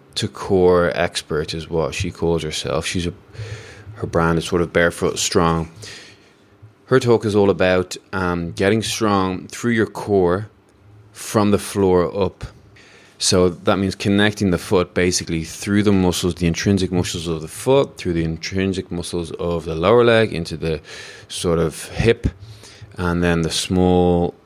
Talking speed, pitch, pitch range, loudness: 160 wpm, 95 Hz, 85-105 Hz, -19 LUFS